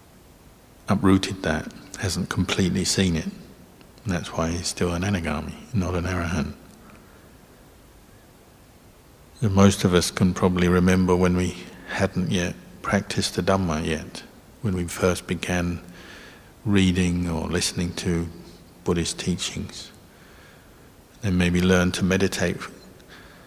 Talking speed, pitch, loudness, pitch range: 120 wpm, 90 Hz, -24 LUFS, 85-95 Hz